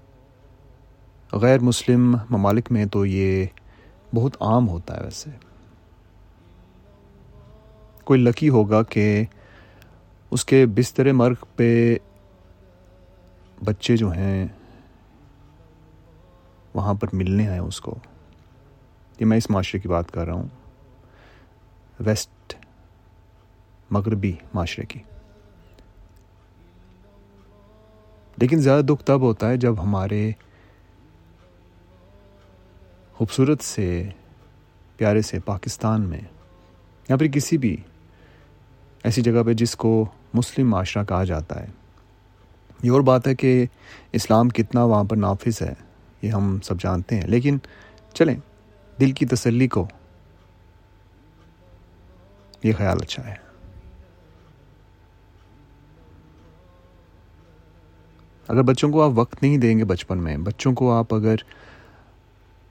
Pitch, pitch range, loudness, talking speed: 100 Hz, 90-115 Hz, -21 LUFS, 105 wpm